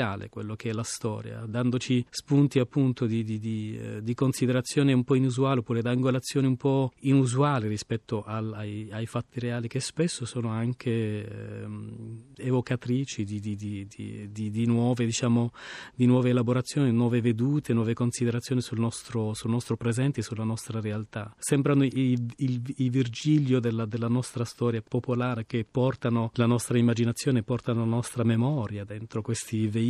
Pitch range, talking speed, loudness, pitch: 115-125 Hz, 155 wpm, -28 LUFS, 120 Hz